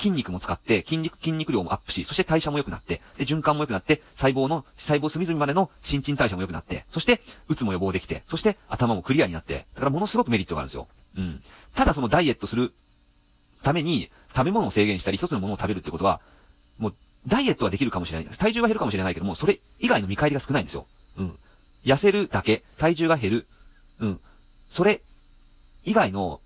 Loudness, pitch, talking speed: -25 LUFS, 120 Hz, 460 characters per minute